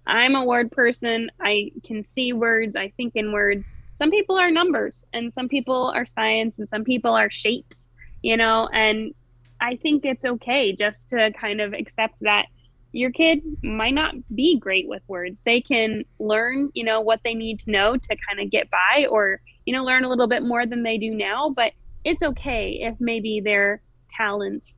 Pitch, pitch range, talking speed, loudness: 225 Hz, 210-255 Hz, 195 wpm, -22 LUFS